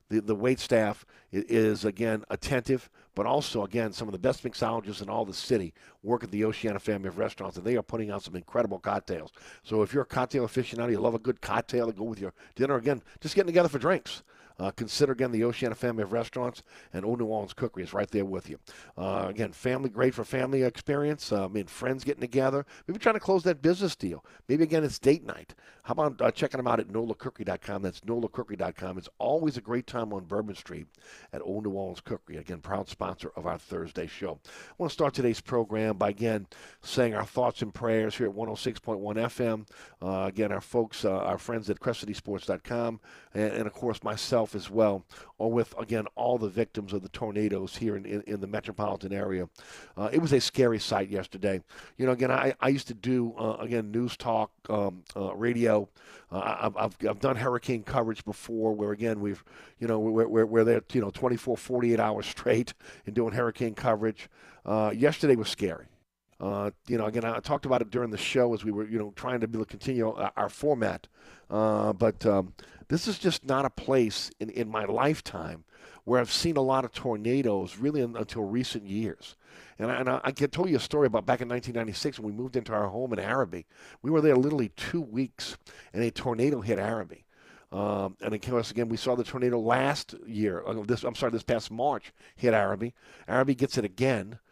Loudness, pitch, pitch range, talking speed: -30 LUFS, 115 Hz, 105-125 Hz, 215 wpm